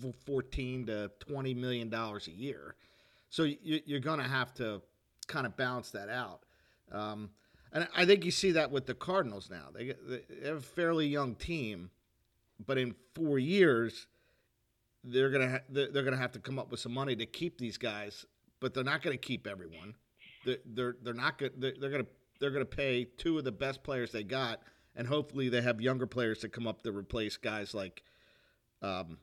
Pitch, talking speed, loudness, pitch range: 125 Hz, 190 wpm, -35 LUFS, 115-140 Hz